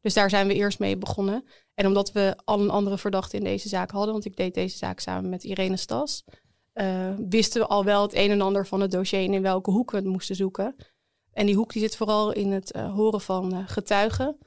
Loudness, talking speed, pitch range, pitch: -25 LUFS, 250 wpm, 190-210 Hz, 200 Hz